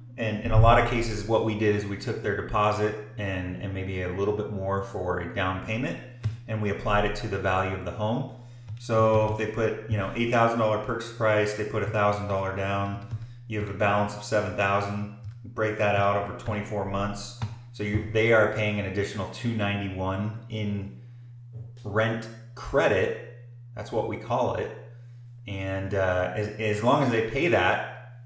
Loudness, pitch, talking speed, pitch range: -27 LUFS, 105 Hz, 180 wpm, 100-115 Hz